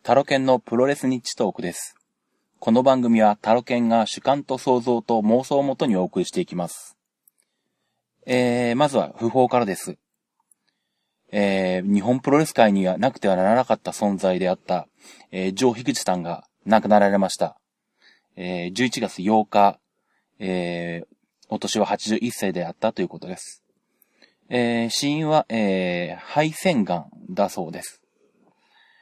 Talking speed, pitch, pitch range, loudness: 295 characters per minute, 115 Hz, 100-130 Hz, -22 LUFS